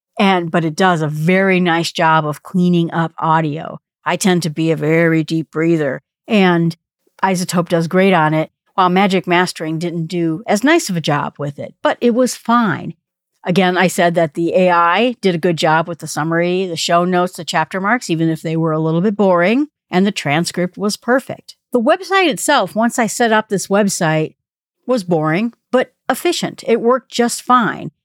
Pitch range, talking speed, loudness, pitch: 165-210 Hz, 195 wpm, -16 LUFS, 180 Hz